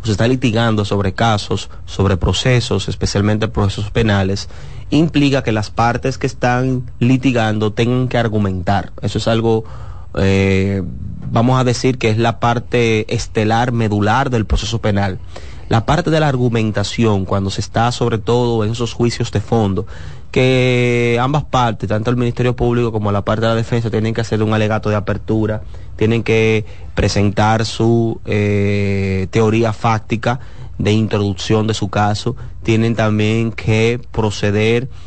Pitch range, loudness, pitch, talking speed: 100-120 Hz, -16 LUFS, 110 Hz, 150 wpm